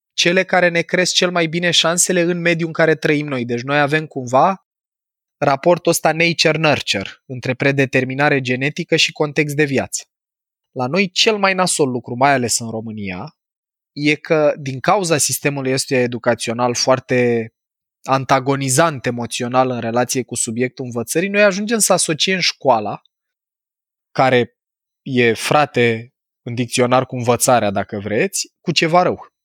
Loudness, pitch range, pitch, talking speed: -17 LUFS, 125-170 Hz, 140 Hz, 145 wpm